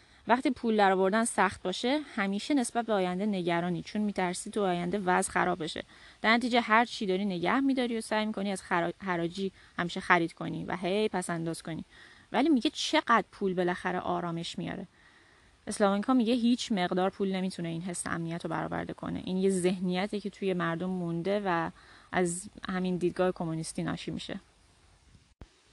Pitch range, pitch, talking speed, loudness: 175-215 Hz, 185 Hz, 170 wpm, -30 LUFS